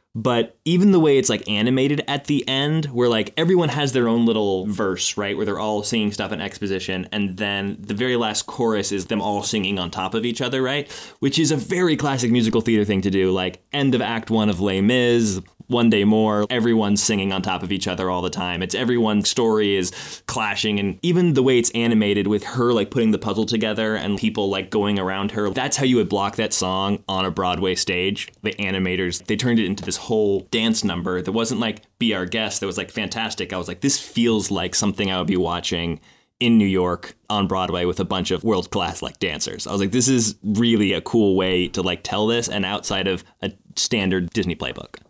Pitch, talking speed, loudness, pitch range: 105 Hz, 230 wpm, -21 LUFS, 95-120 Hz